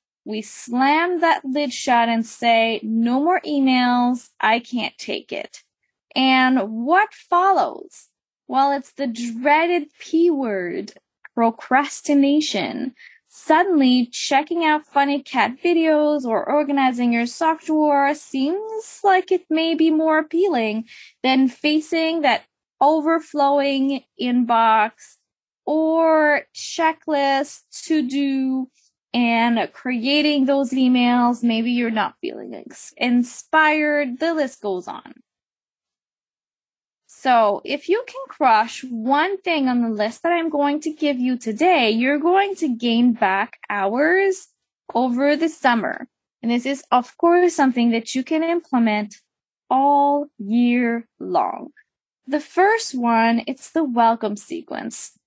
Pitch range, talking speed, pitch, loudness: 240-315 Hz, 120 wpm, 275 Hz, -19 LUFS